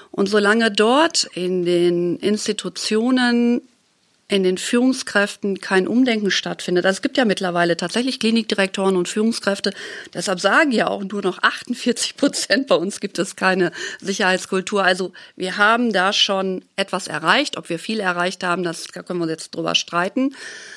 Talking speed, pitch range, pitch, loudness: 155 wpm, 185-230 Hz, 200 Hz, -19 LUFS